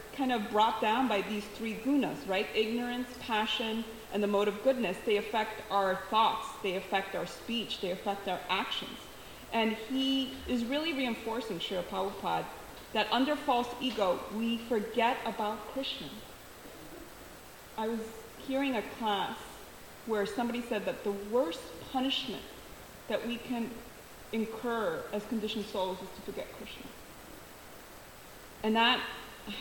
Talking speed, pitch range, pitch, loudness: 140 wpm, 210-245 Hz, 225 Hz, -33 LUFS